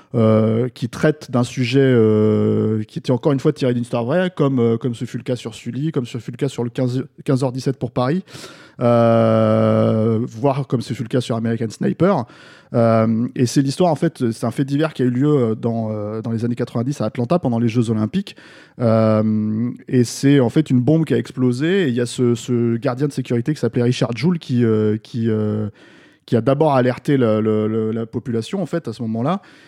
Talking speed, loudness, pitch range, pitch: 225 wpm, -19 LUFS, 115-140 Hz, 120 Hz